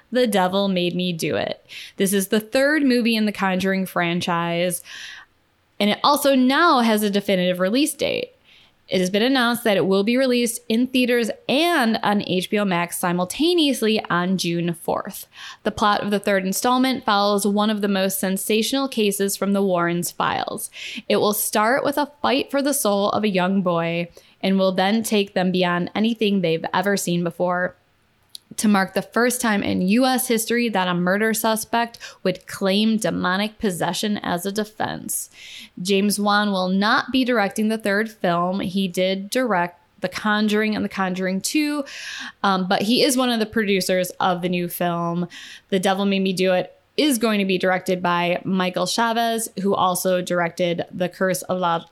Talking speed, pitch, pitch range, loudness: 180 wpm, 200 Hz, 185-225 Hz, -21 LUFS